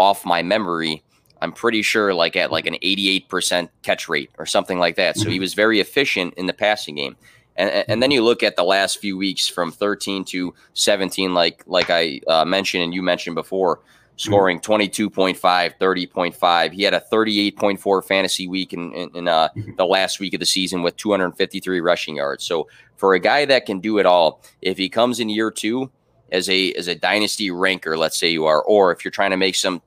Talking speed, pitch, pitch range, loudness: 205 wpm, 95 Hz, 90-100 Hz, -19 LUFS